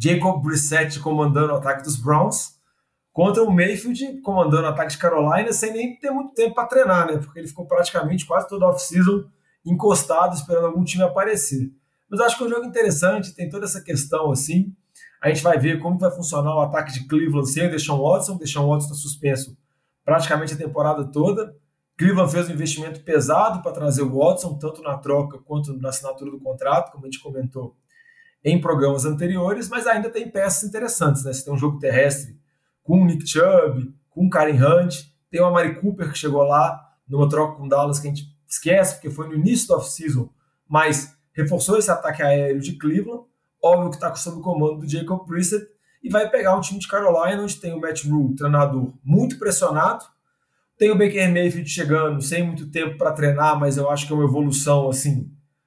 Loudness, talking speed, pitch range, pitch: -20 LUFS, 200 wpm, 145-185 Hz, 160 Hz